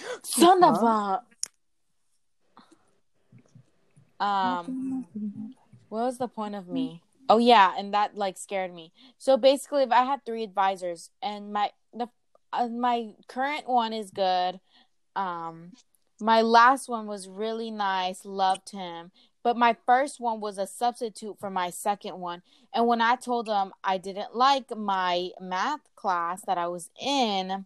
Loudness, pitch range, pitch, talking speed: -26 LUFS, 190-245 Hz, 220 Hz, 150 wpm